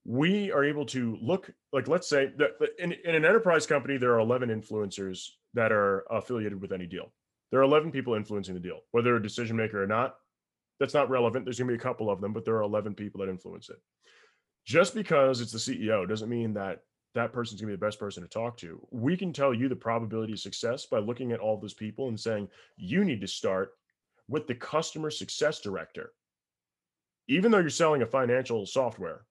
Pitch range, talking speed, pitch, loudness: 105-140 Hz, 220 wpm, 120 Hz, -29 LUFS